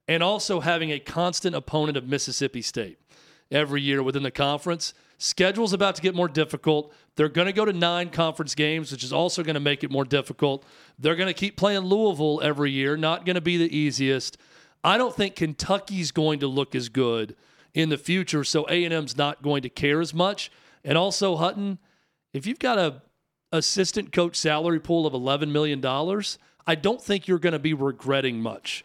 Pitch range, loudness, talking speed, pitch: 145-180 Hz, -25 LUFS, 200 wpm, 155 Hz